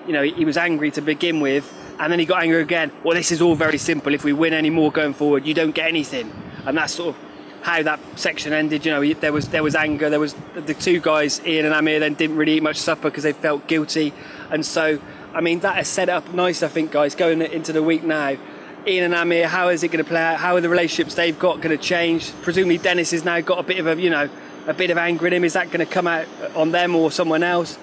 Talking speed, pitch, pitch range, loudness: 265 wpm, 160 Hz, 155-170 Hz, -20 LUFS